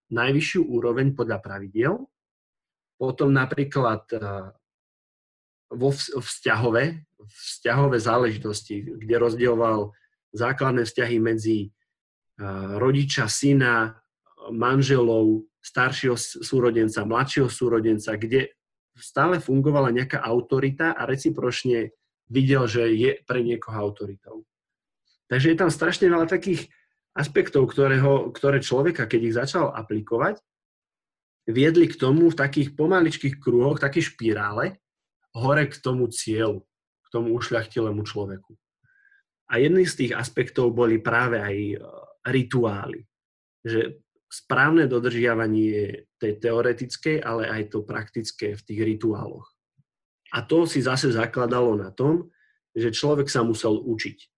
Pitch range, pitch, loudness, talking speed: 110-140 Hz, 120 Hz, -23 LUFS, 110 wpm